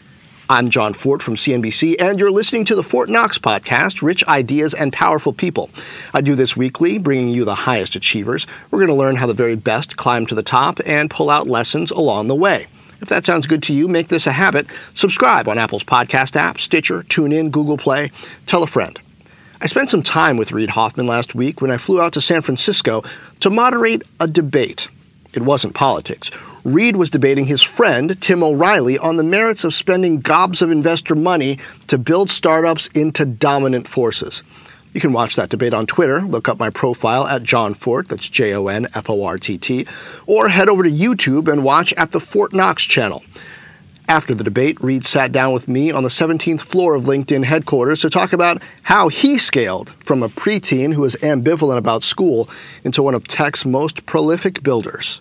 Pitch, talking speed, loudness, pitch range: 150 Hz, 200 wpm, -15 LUFS, 130-170 Hz